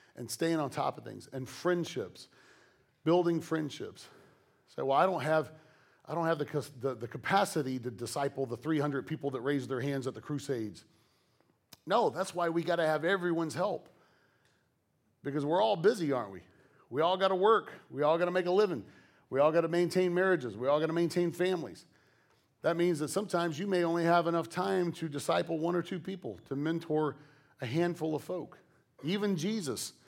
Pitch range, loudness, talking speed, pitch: 145-175 Hz, -32 LUFS, 195 wpm, 165 Hz